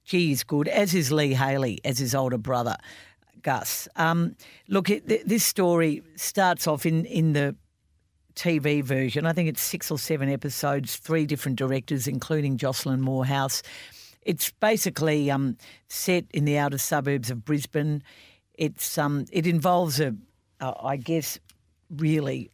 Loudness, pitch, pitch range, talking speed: -26 LUFS, 150 Hz, 135-165 Hz, 150 wpm